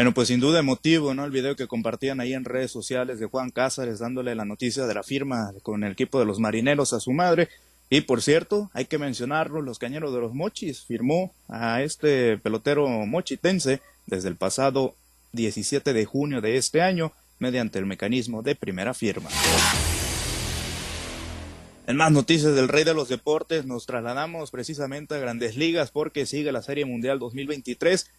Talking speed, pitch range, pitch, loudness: 175 wpm, 115-145 Hz, 130 Hz, -25 LUFS